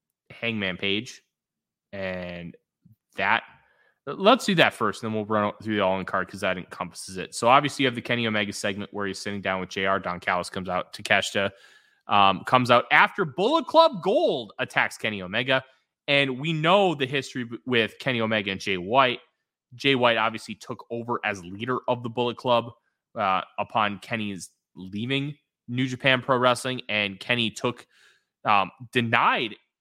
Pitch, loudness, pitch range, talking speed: 115 Hz, -24 LUFS, 100-130 Hz, 170 wpm